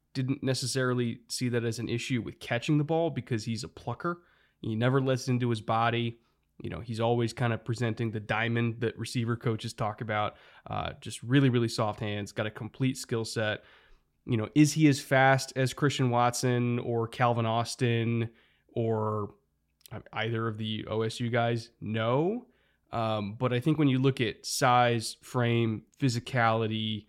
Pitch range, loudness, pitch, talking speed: 115-130 Hz, -29 LUFS, 120 Hz, 170 wpm